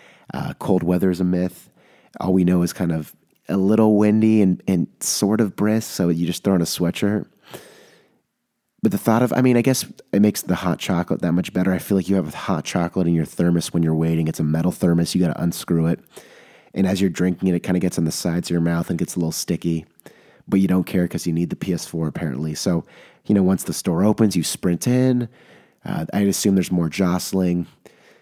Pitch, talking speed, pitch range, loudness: 90 Hz, 240 wpm, 85-100 Hz, -20 LUFS